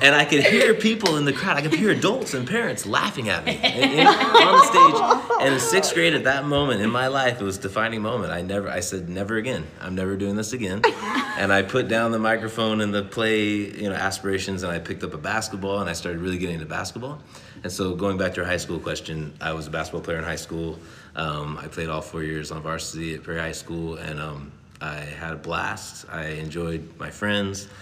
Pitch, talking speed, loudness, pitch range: 95 Hz, 235 wpm, -22 LUFS, 80-110 Hz